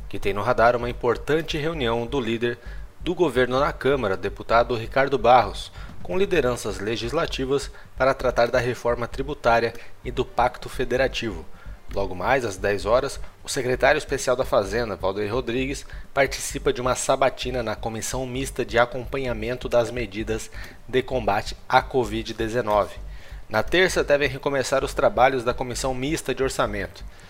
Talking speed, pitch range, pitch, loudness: 145 wpm, 110-130 Hz, 120 Hz, -24 LUFS